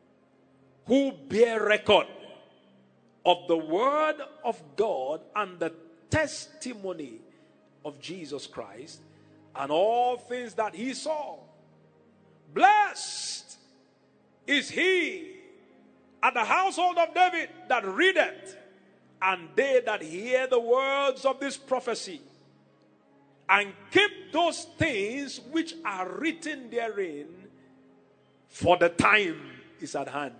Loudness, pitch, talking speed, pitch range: -27 LUFS, 260 Hz, 105 wpm, 195-330 Hz